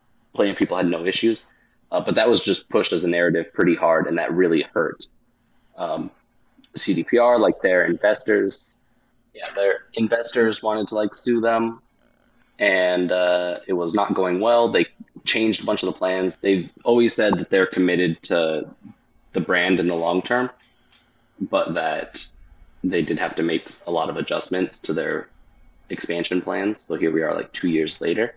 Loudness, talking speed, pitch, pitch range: -21 LUFS, 180 wpm, 105 Hz, 90-115 Hz